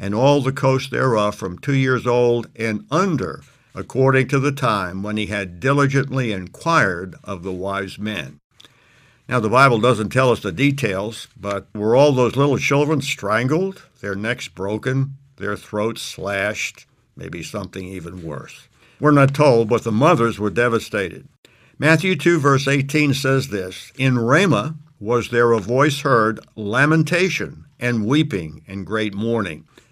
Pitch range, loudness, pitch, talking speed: 105-140 Hz, -19 LUFS, 120 Hz, 150 wpm